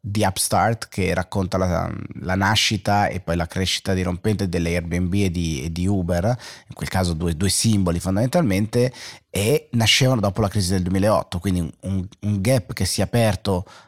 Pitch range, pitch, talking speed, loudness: 90-110 Hz, 95 Hz, 175 wpm, -21 LUFS